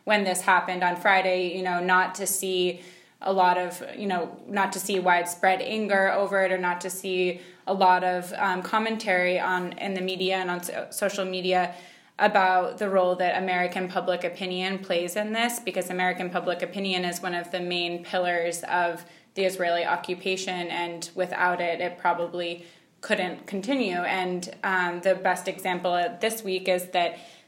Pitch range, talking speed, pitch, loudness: 180-190 Hz, 175 wpm, 185 Hz, -26 LUFS